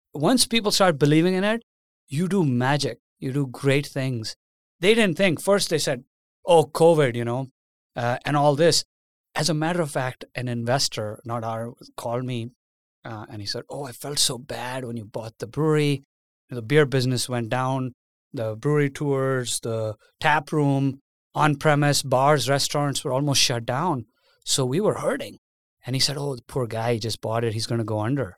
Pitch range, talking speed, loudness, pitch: 120-150 Hz, 195 wpm, -23 LUFS, 135 Hz